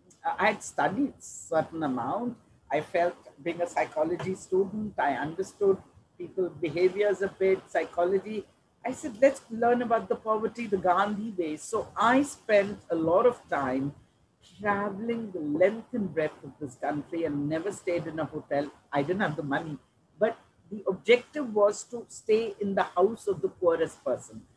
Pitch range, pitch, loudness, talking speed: 170-230 Hz, 195 Hz, -29 LUFS, 165 wpm